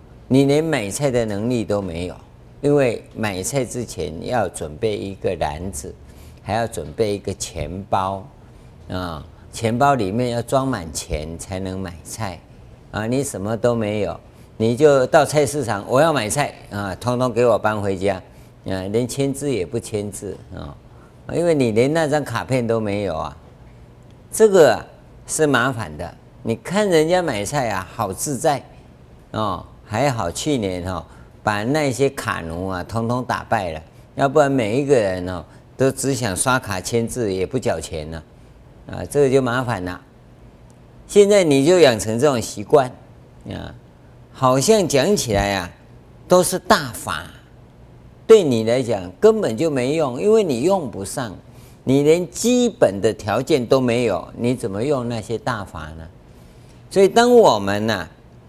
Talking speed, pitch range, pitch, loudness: 225 characters per minute, 95-135 Hz, 115 Hz, -19 LUFS